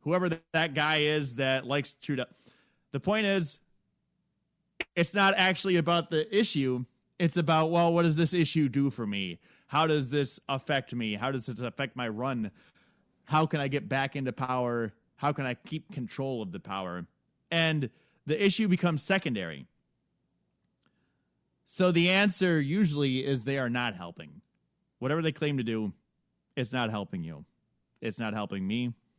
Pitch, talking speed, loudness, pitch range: 140 Hz, 160 wpm, -29 LUFS, 125-165 Hz